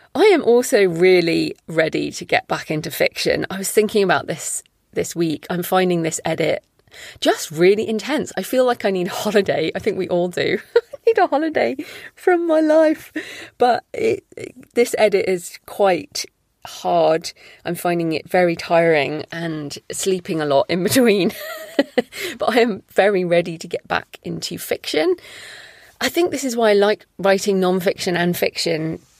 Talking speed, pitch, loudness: 170 wpm, 205 Hz, -19 LUFS